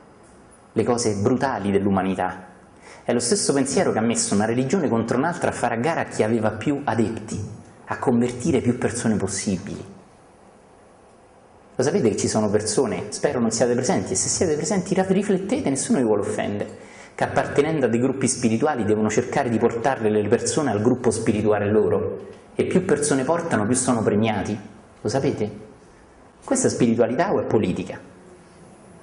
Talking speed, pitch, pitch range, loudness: 165 wpm, 115 Hz, 105-130 Hz, -22 LUFS